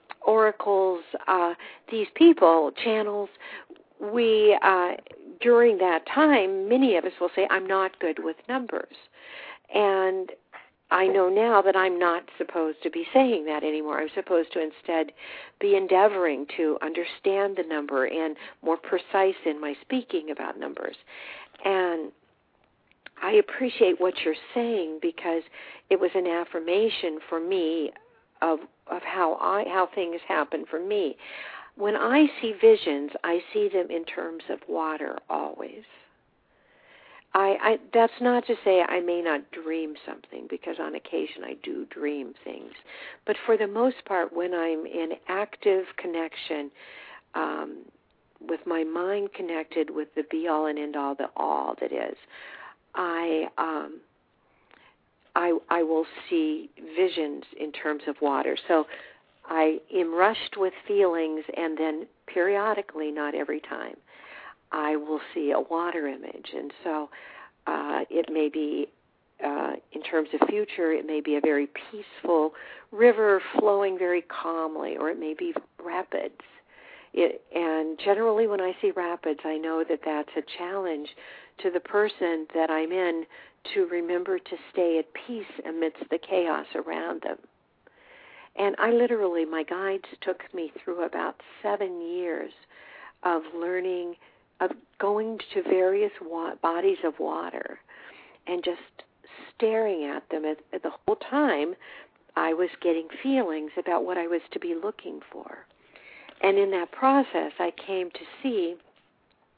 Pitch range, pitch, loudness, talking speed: 160-210 Hz, 180 Hz, -26 LUFS, 145 wpm